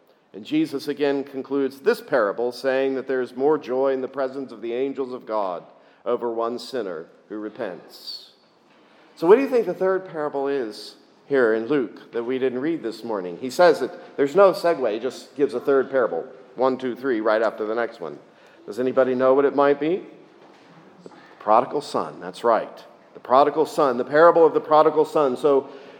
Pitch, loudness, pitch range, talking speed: 135 Hz, -22 LUFS, 125-150 Hz, 195 wpm